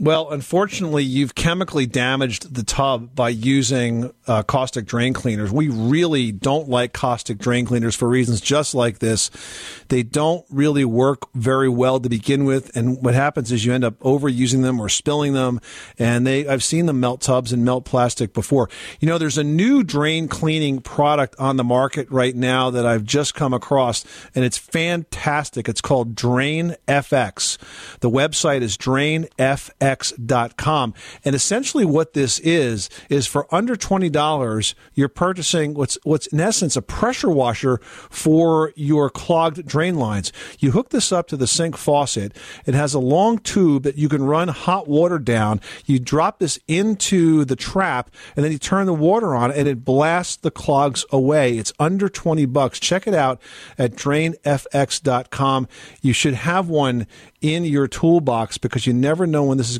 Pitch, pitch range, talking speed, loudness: 140 Hz, 125-155 Hz, 175 wpm, -19 LUFS